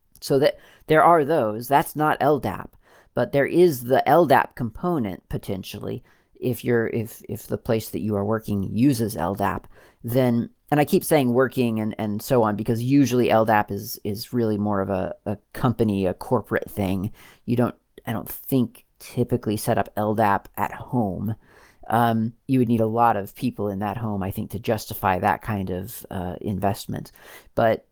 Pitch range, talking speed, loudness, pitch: 100-120 Hz, 180 wpm, -23 LUFS, 110 Hz